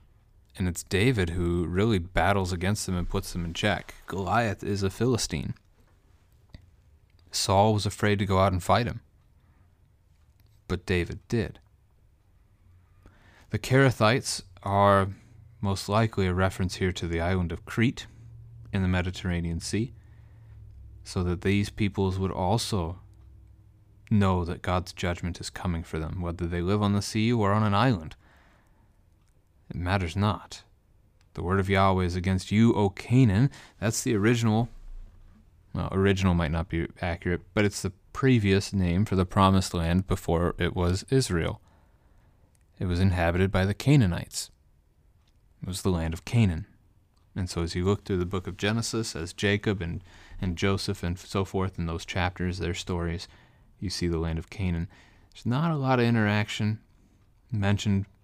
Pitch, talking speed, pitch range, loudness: 95 Hz, 155 wpm, 90-105 Hz, -27 LUFS